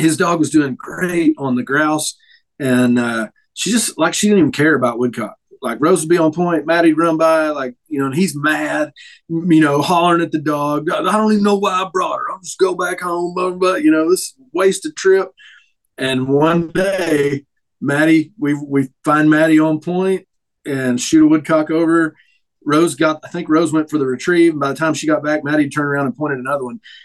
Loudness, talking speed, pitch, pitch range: -16 LUFS, 220 wpm, 160 Hz, 145-180 Hz